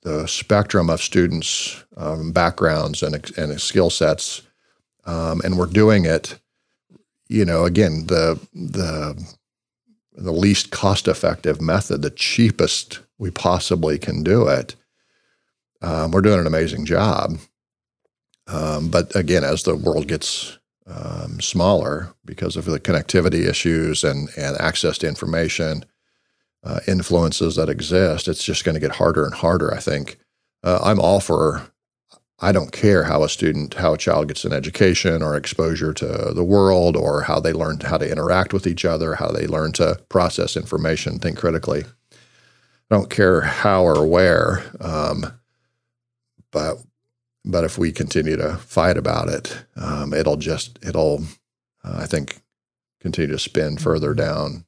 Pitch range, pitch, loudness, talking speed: 80-95 Hz, 85 Hz, -19 LUFS, 150 wpm